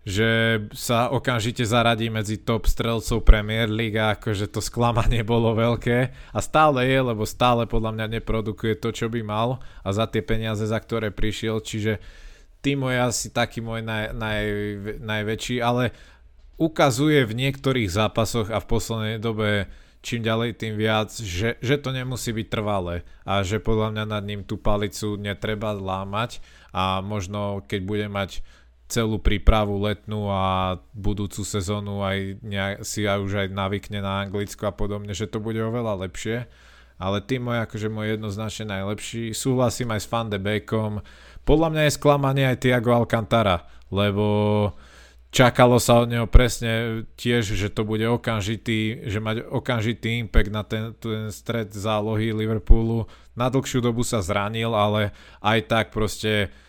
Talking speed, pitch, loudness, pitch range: 160 wpm, 110 Hz, -24 LUFS, 105-115 Hz